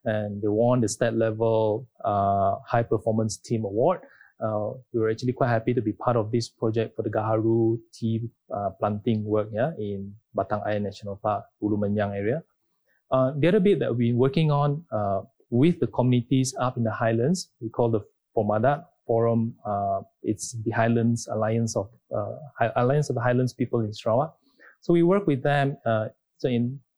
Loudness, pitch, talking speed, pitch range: -25 LUFS, 115 Hz, 180 wpm, 105-125 Hz